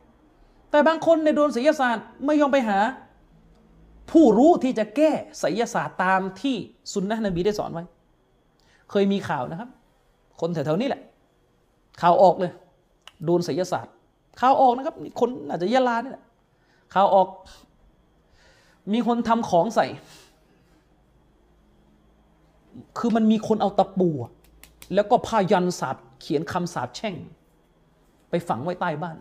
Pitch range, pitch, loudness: 175-245 Hz, 200 Hz, -23 LUFS